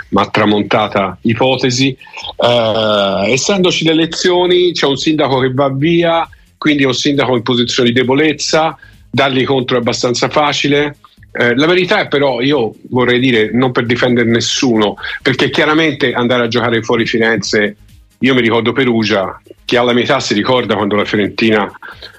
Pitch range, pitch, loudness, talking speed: 115-145 Hz, 125 Hz, -12 LUFS, 155 wpm